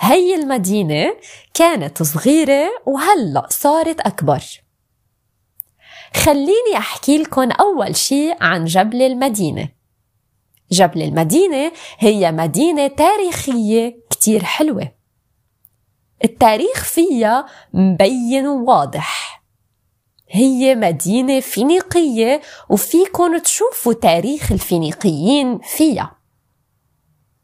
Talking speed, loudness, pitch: 75 wpm, -15 LUFS, 250 Hz